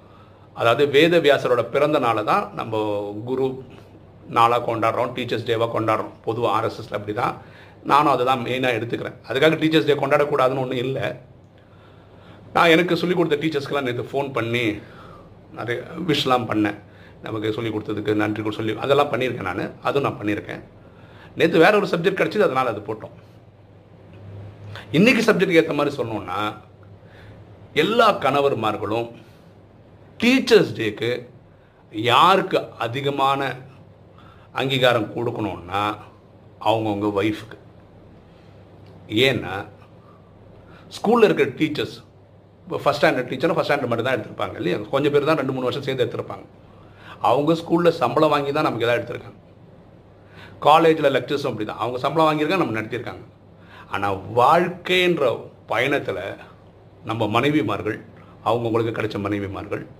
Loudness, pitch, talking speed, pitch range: -21 LUFS, 115 Hz, 120 wpm, 105-140 Hz